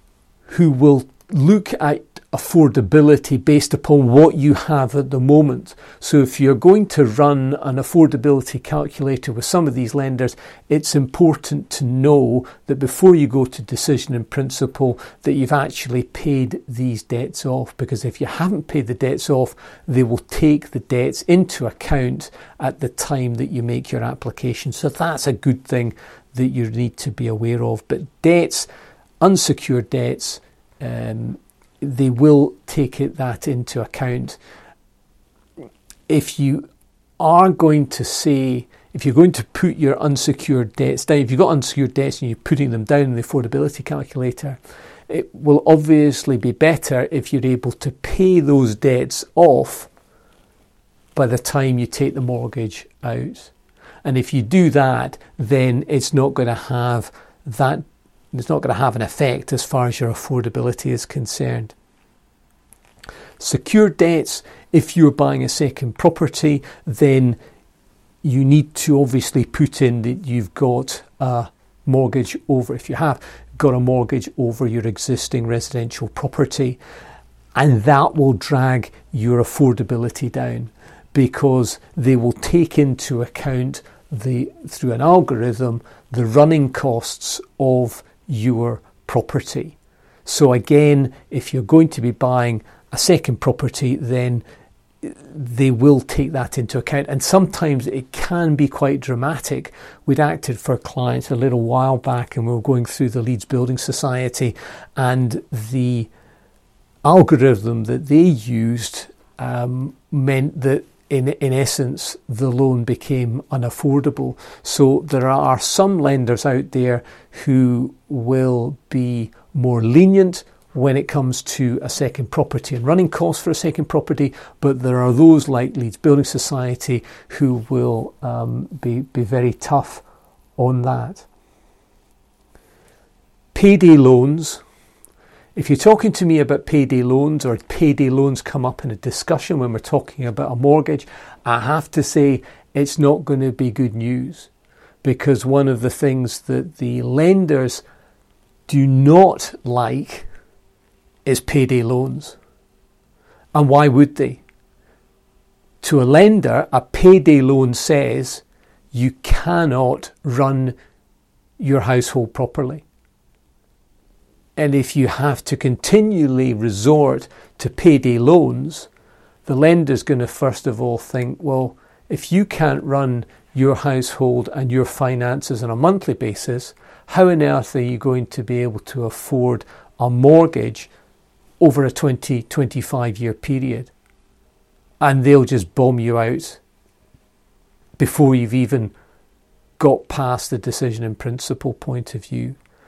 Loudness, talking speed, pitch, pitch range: -17 LUFS, 145 wpm, 135 Hz, 125-145 Hz